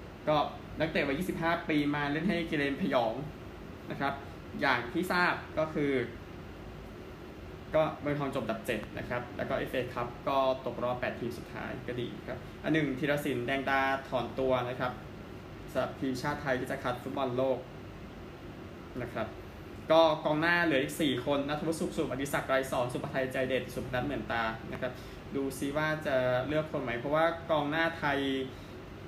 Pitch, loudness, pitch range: 135 Hz, -32 LUFS, 125-155 Hz